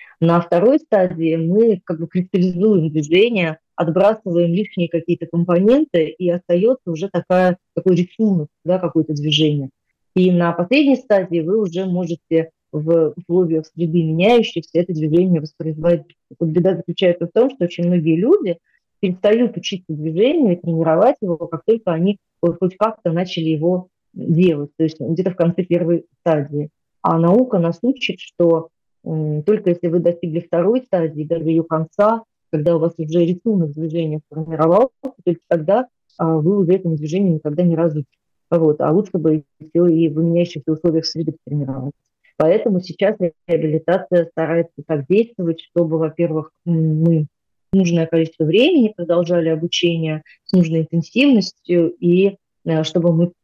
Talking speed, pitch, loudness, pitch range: 145 wpm, 170 Hz, -18 LUFS, 160-185 Hz